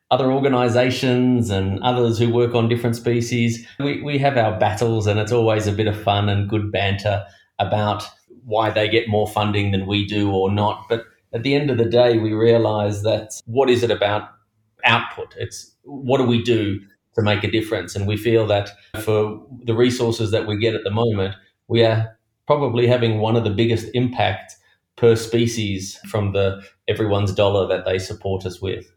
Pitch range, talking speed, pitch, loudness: 105-120 Hz, 190 wpm, 110 Hz, -20 LUFS